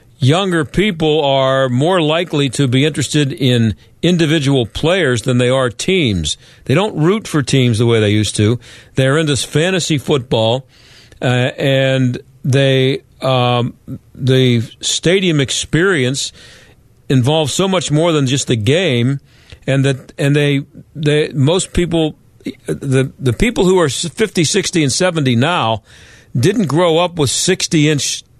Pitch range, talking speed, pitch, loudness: 125-155 Hz, 140 wpm, 135 Hz, -14 LUFS